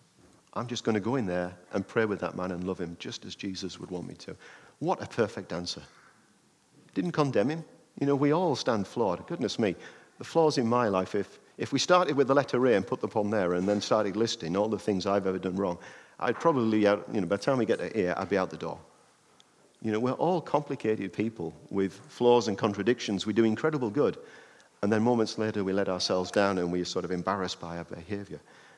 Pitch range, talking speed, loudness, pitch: 95-120 Hz, 235 wpm, -29 LUFS, 100 Hz